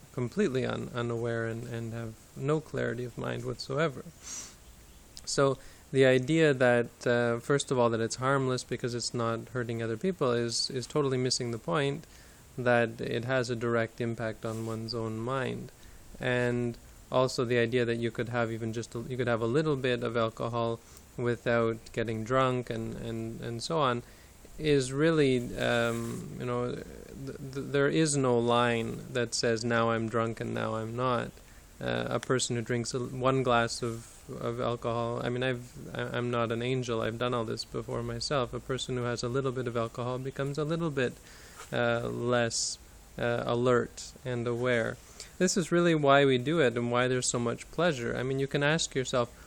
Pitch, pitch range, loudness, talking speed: 120 Hz, 115-130 Hz, -30 LUFS, 185 wpm